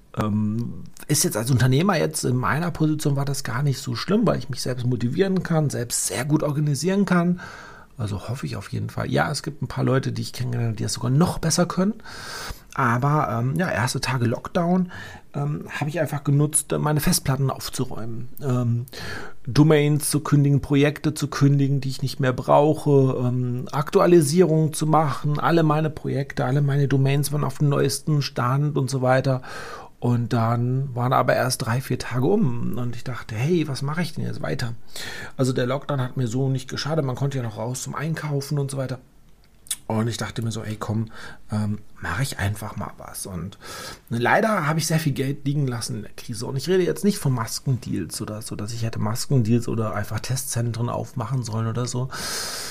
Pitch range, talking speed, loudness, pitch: 120-150 Hz, 200 wpm, -23 LUFS, 135 Hz